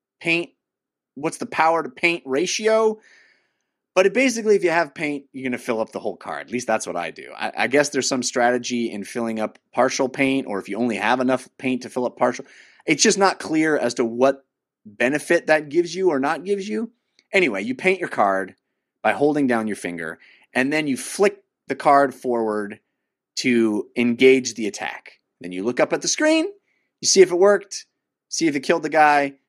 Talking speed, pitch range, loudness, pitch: 210 wpm, 120-190 Hz, -21 LUFS, 140 Hz